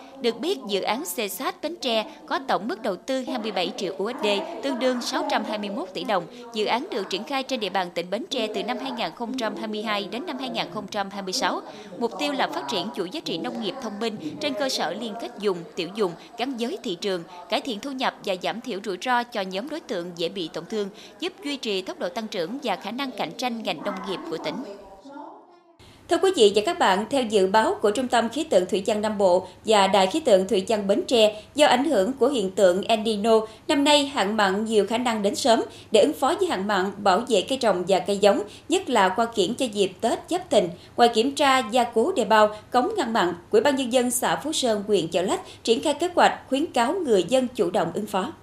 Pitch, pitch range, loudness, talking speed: 230 Hz, 200-270 Hz, -24 LUFS, 240 wpm